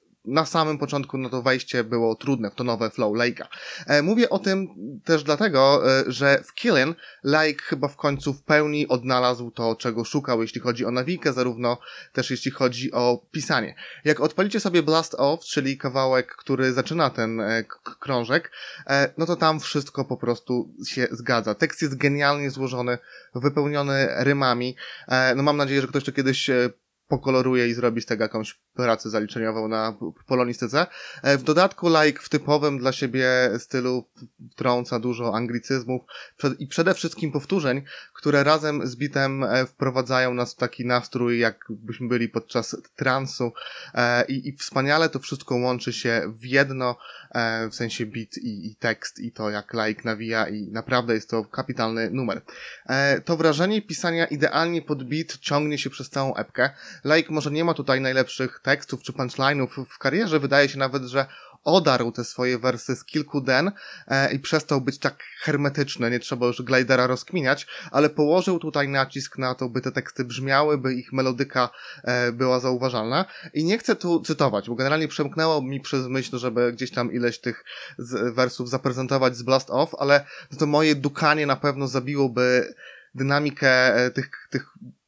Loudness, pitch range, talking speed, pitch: -23 LUFS, 125-145 Hz, 165 wpm, 135 Hz